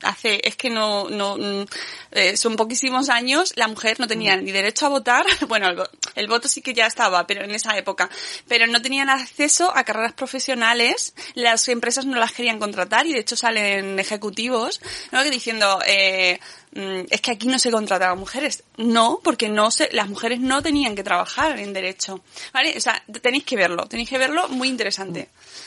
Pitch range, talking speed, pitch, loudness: 200-260 Hz, 185 wpm, 230 Hz, -20 LUFS